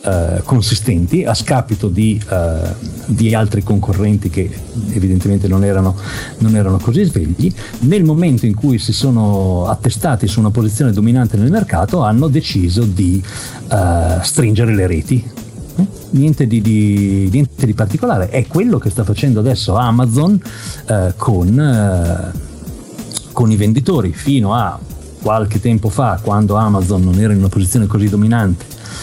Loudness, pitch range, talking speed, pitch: -14 LUFS, 95-120 Hz, 145 wpm, 110 Hz